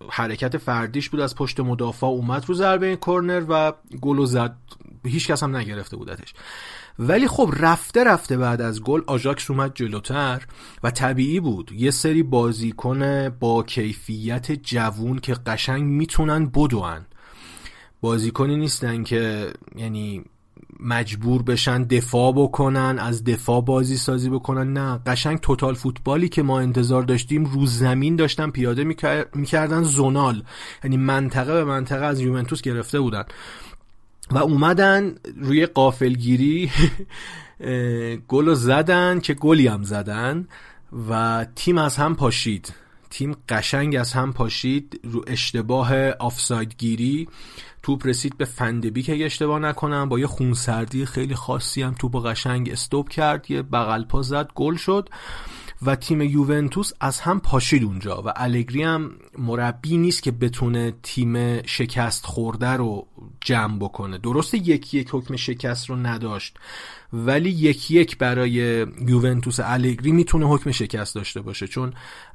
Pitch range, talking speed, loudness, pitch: 120-145 Hz, 135 wpm, -22 LUFS, 130 Hz